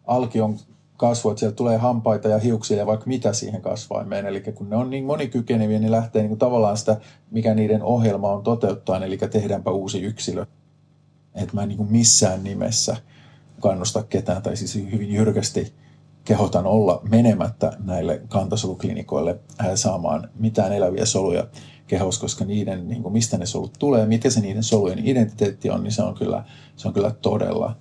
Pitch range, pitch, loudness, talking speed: 105-120 Hz, 110 Hz, -22 LUFS, 175 wpm